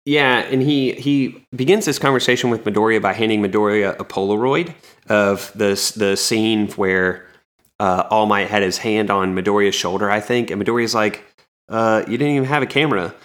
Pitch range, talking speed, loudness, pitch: 100-125 Hz, 180 wpm, -18 LUFS, 110 Hz